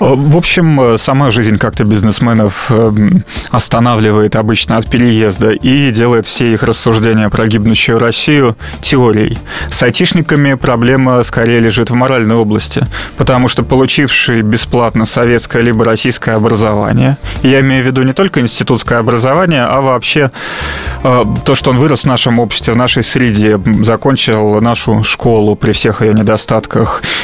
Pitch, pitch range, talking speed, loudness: 120 Hz, 110-130 Hz, 135 wpm, -9 LUFS